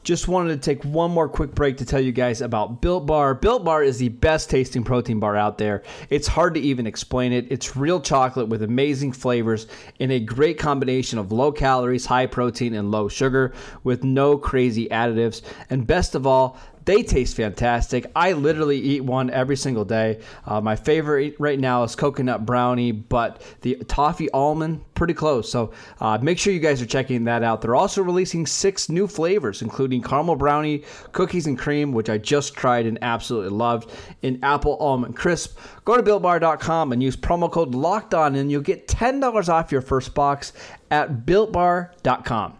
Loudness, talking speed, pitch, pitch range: -21 LUFS, 185 wpm, 135 Hz, 120-155 Hz